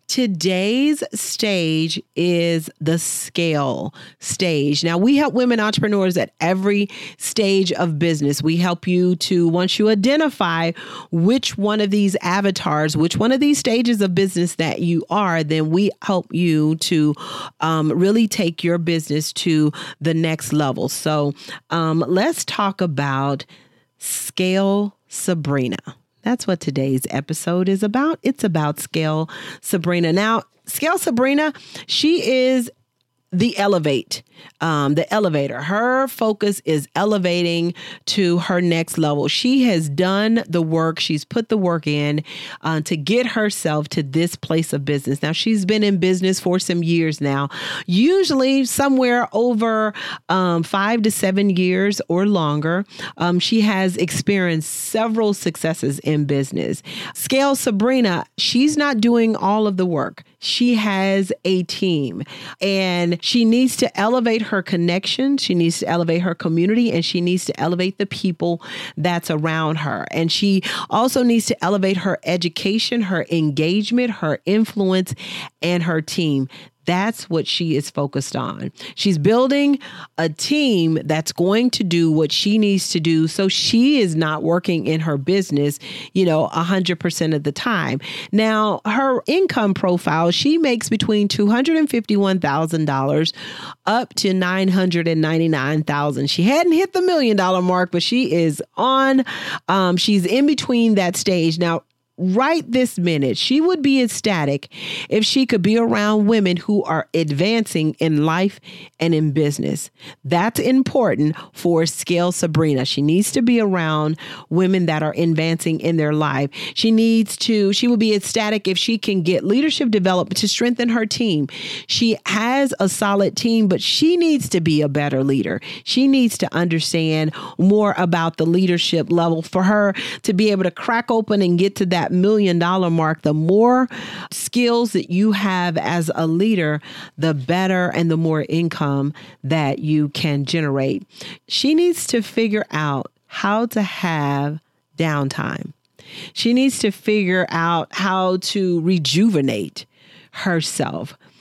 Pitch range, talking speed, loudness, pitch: 160-215 Hz, 150 wpm, -18 LUFS, 185 Hz